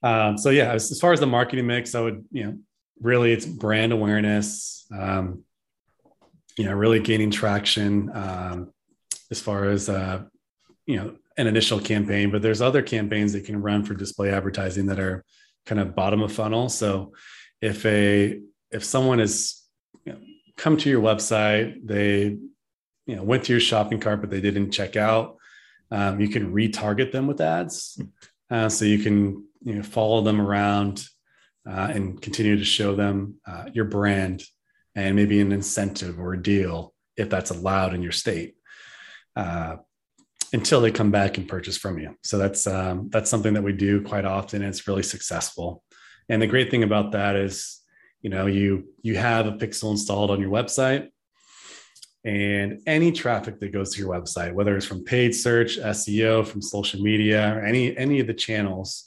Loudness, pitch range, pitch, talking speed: -23 LUFS, 100-110 Hz, 105 Hz, 180 wpm